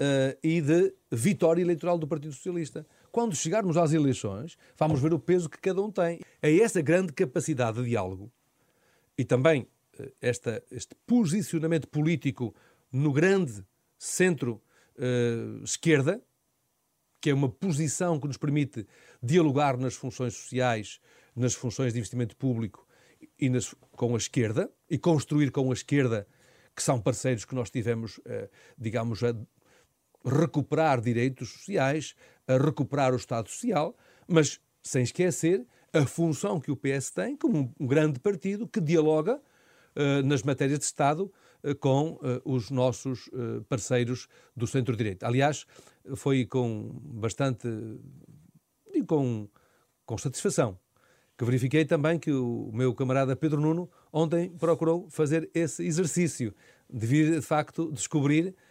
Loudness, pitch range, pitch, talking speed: -28 LUFS, 125-165 Hz, 140 Hz, 140 wpm